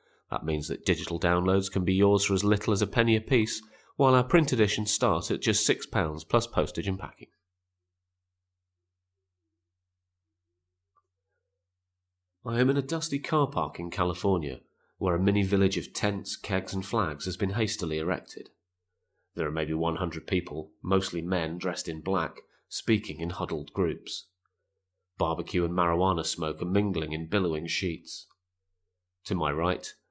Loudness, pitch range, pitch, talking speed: -28 LUFS, 85-100 Hz, 90 Hz, 155 wpm